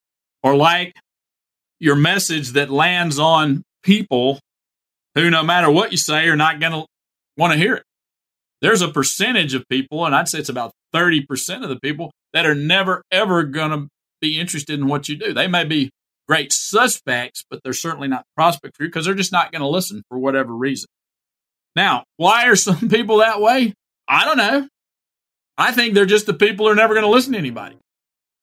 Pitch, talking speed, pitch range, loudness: 160 Hz, 200 wpm, 140-185 Hz, -17 LUFS